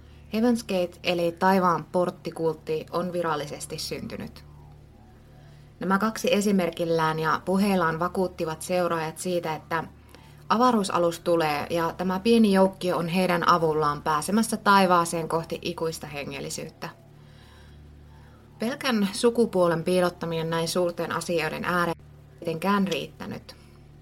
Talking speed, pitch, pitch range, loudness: 100 wpm, 175 Hz, 160-185 Hz, -25 LUFS